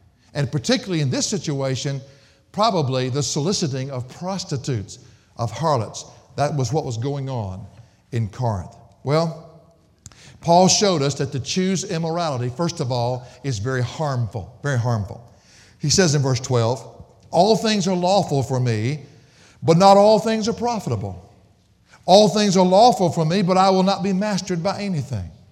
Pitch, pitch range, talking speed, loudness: 140 Hz, 120-180 Hz, 160 wpm, -20 LUFS